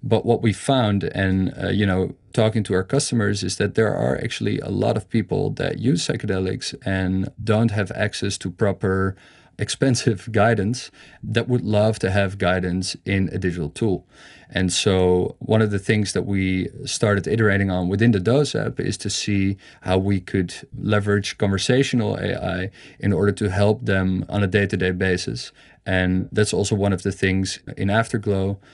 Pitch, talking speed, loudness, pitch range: 100 Hz, 175 wpm, -22 LUFS, 95-115 Hz